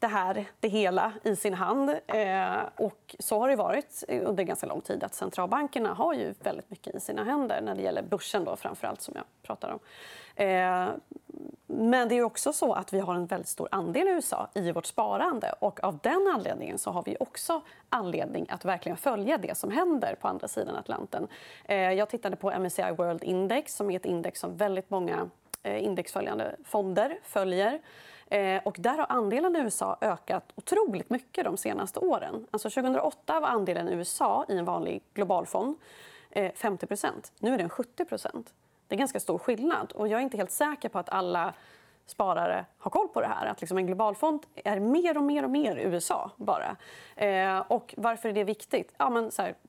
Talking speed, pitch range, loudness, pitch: 195 wpm, 195-295 Hz, -30 LUFS, 220 Hz